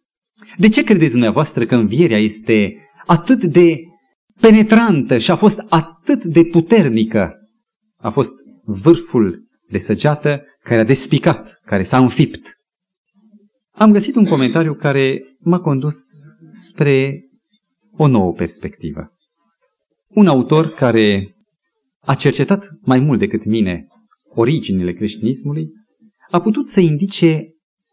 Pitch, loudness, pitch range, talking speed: 165 Hz, -15 LUFS, 130-210 Hz, 115 wpm